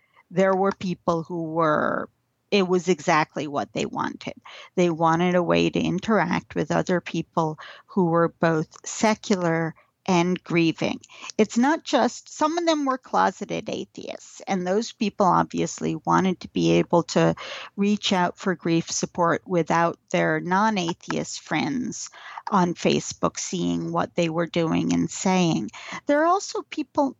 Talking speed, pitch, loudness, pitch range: 150 wpm, 175 Hz, -24 LUFS, 165-205 Hz